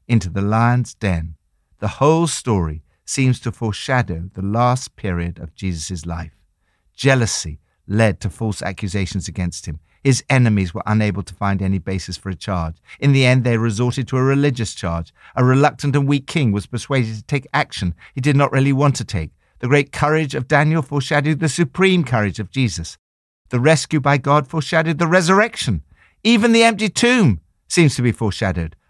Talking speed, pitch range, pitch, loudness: 180 wpm, 90-140 Hz, 115 Hz, -18 LUFS